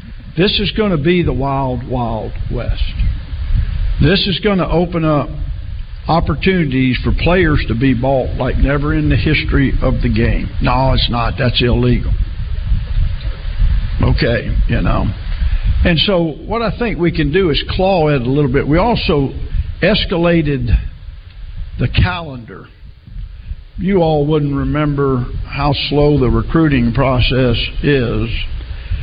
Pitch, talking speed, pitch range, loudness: 125 Hz, 140 wpm, 95-150 Hz, -15 LUFS